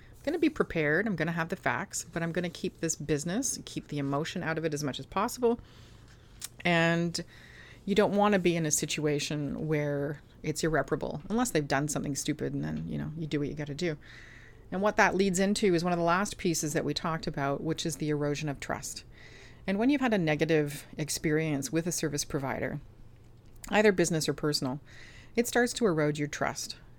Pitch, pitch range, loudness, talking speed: 155 Hz, 140-175 Hz, -30 LUFS, 215 wpm